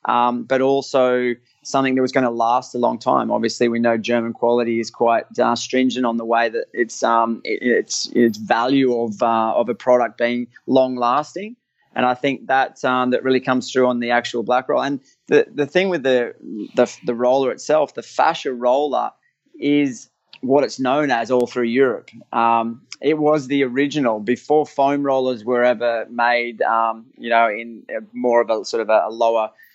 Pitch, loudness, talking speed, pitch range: 125 Hz, -19 LUFS, 195 wpm, 115-135 Hz